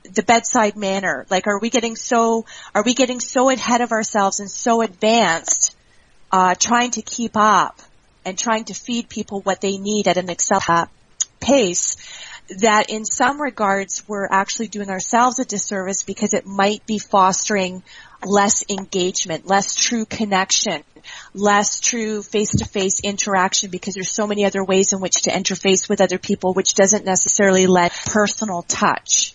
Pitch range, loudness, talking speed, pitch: 190-220 Hz, -18 LUFS, 165 wpm, 200 Hz